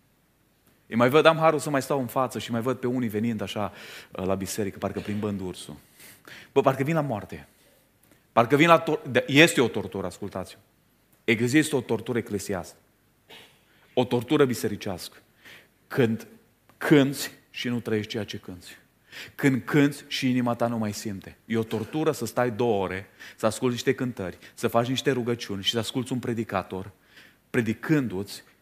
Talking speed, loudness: 170 wpm, -26 LUFS